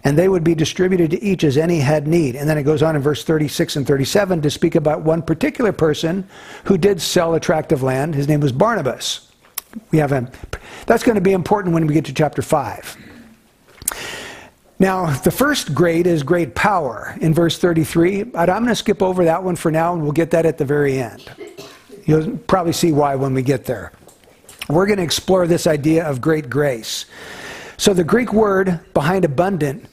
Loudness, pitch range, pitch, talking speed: -17 LUFS, 150-185 Hz, 165 Hz, 205 wpm